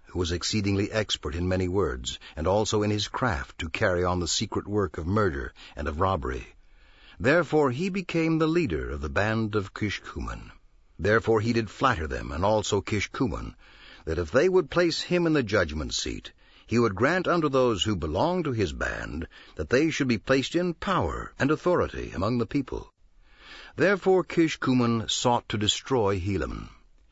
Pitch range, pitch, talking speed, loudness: 95-150 Hz, 110 Hz, 175 wpm, -26 LUFS